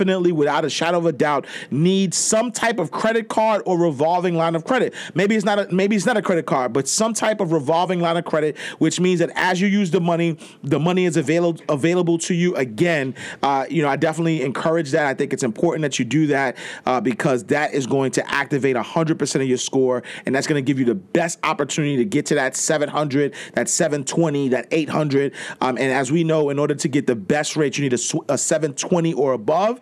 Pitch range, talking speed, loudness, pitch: 145-175 Hz, 230 wpm, -20 LUFS, 160 Hz